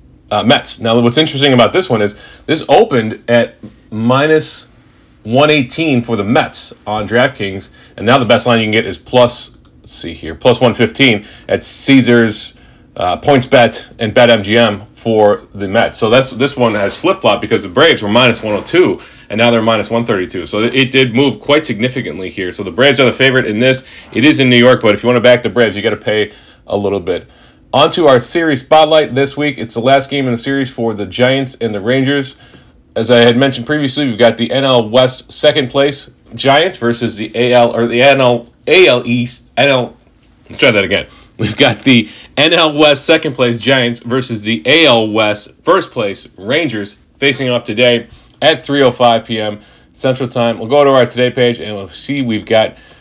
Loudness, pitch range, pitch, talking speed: -12 LUFS, 115-135 Hz, 120 Hz, 210 wpm